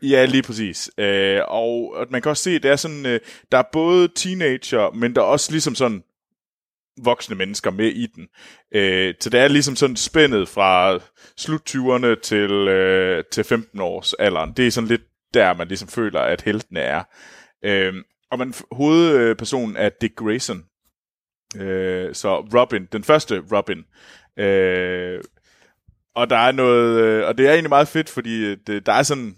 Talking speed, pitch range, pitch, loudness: 165 wpm, 100-140 Hz, 120 Hz, -19 LUFS